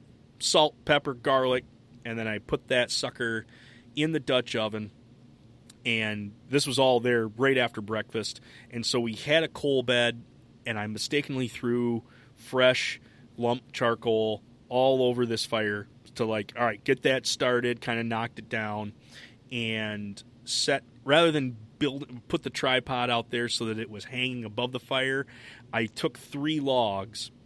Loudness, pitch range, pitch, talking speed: -28 LUFS, 115-130 Hz, 120 Hz, 160 wpm